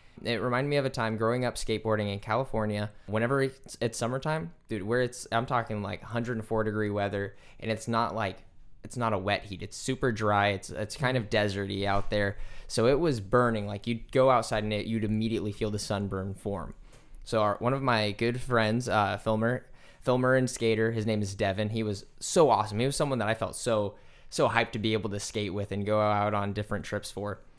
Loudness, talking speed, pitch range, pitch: -29 LUFS, 220 wpm, 100-120 Hz, 110 Hz